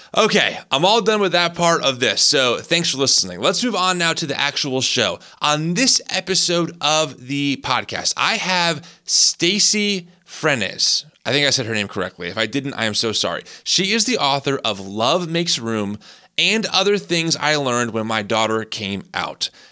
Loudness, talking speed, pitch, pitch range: -18 LUFS, 190 wpm, 150 Hz, 120-180 Hz